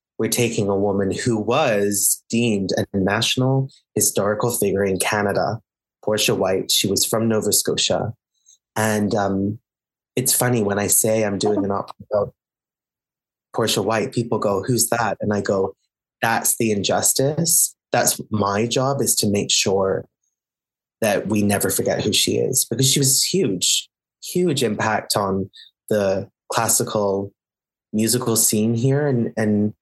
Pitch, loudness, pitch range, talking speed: 110 Hz, -19 LUFS, 100-120 Hz, 145 wpm